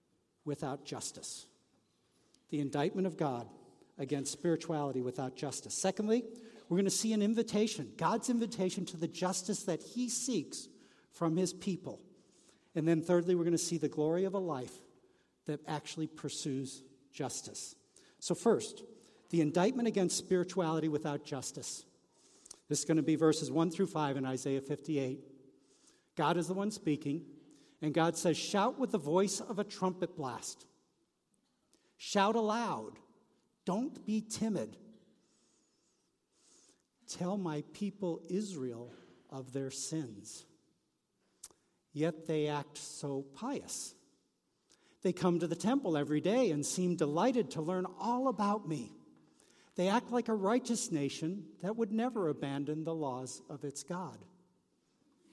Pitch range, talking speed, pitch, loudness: 150-200 Hz, 135 wpm, 170 Hz, -35 LUFS